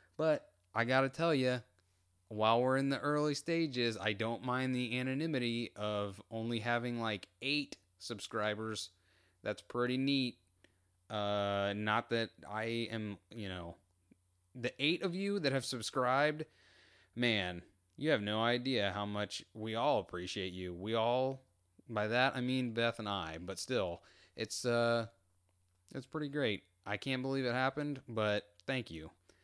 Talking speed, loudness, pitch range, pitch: 150 wpm, -36 LUFS, 95-130 Hz, 110 Hz